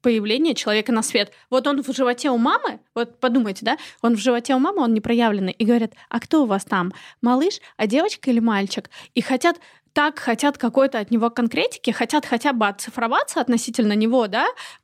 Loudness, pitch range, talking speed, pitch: -21 LUFS, 225-275 Hz, 195 wpm, 240 Hz